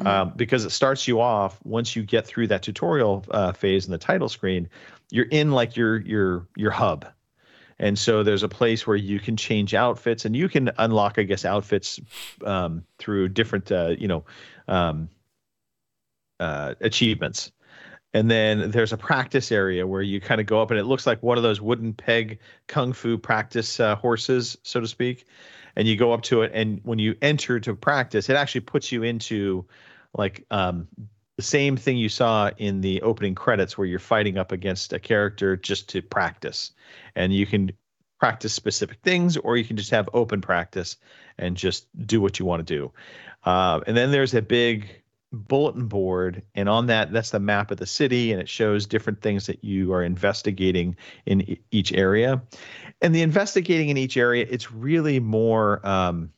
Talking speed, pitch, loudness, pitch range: 190 wpm, 110 Hz, -23 LUFS, 100-120 Hz